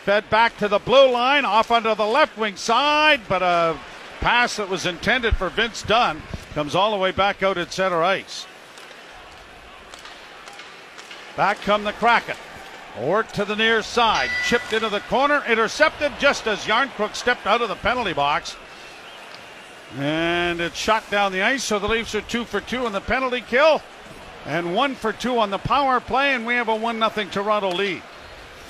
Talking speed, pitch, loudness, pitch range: 180 wpm, 220 Hz, -20 LUFS, 195-240 Hz